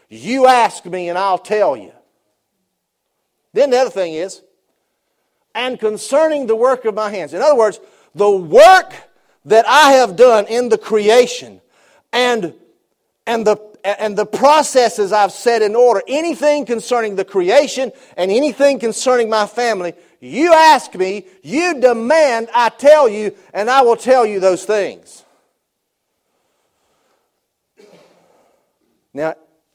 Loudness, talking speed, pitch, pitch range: -14 LUFS, 135 wpm, 230 Hz, 205-265 Hz